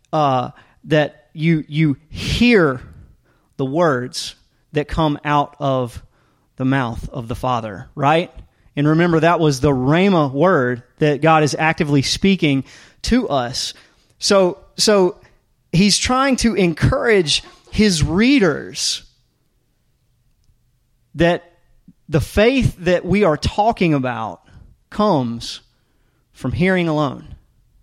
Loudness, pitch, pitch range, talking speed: -17 LUFS, 150 Hz, 125-175 Hz, 110 wpm